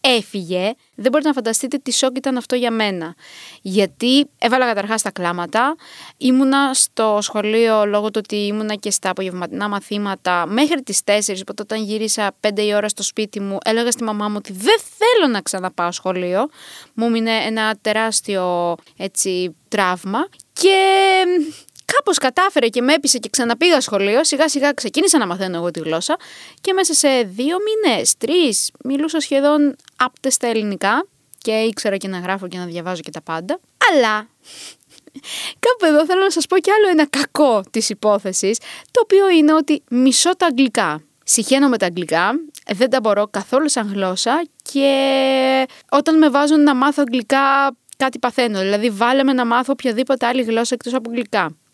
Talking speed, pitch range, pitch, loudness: 165 wpm, 205-285 Hz, 240 Hz, -17 LUFS